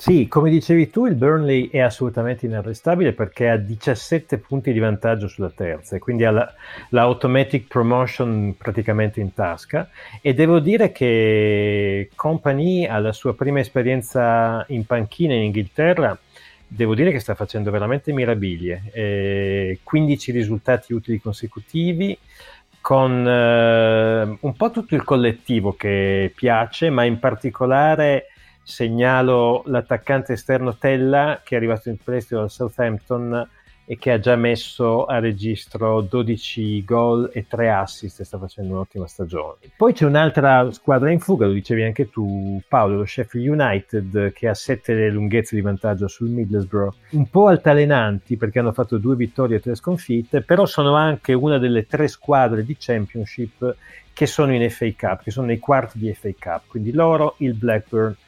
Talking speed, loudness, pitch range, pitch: 155 wpm, -19 LUFS, 110-135 Hz, 120 Hz